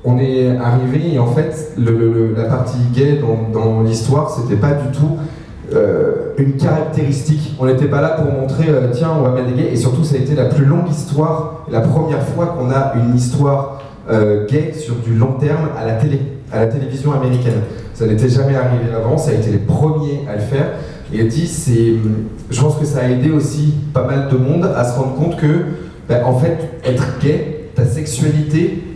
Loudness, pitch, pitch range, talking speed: -15 LUFS, 140 Hz, 125-155 Hz, 210 wpm